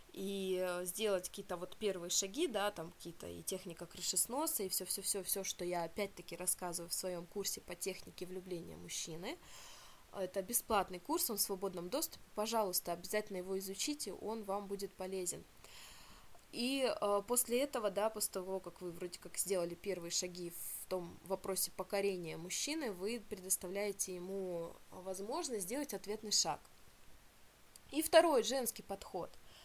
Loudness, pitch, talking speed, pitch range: -39 LUFS, 195 Hz, 140 wpm, 180-210 Hz